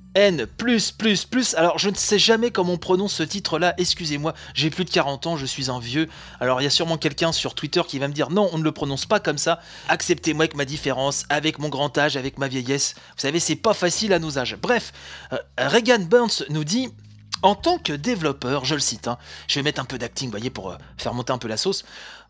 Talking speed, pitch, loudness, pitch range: 245 wpm, 155 Hz, -22 LUFS, 135-185 Hz